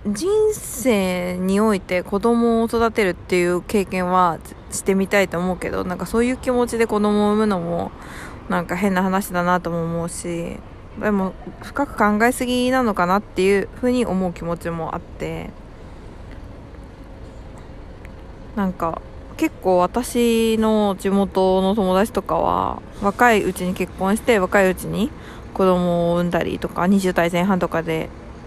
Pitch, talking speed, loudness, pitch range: 195 Hz, 280 characters per minute, -20 LUFS, 180-220 Hz